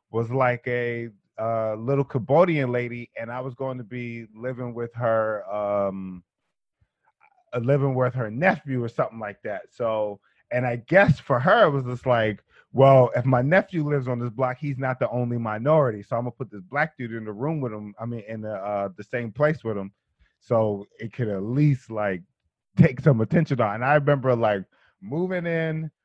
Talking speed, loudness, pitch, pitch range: 200 wpm, -24 LUFS, 125 Hz, 110-140 Hz